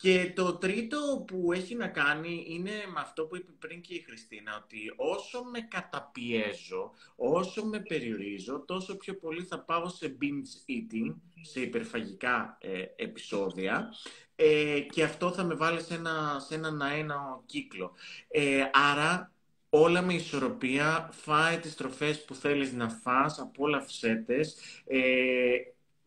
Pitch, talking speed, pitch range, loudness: 160 Hz, 145 wpm, 140-185 Hz, -31 LUFS